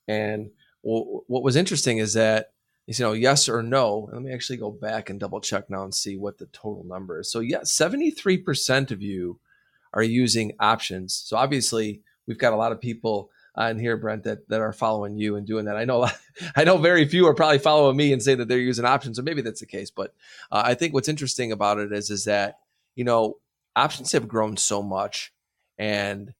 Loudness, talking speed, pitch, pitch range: -23 LUFS, 220 wpm, 115 Hz, 105-130 Hz